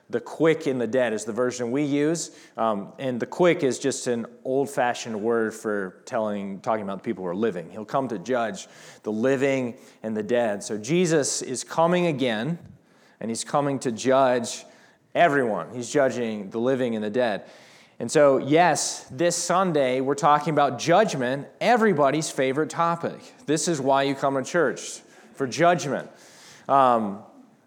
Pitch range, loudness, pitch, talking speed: 120-160 Hz, -24 LUFS, 135 Hz, 165 wpm